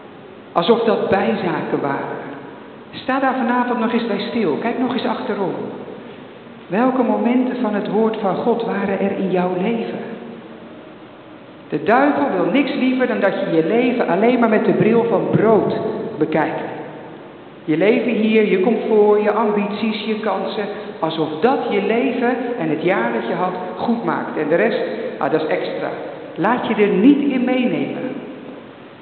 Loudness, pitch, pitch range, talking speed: -18 LUFS, 220 Hz, 205-245 Hz, 165 wpm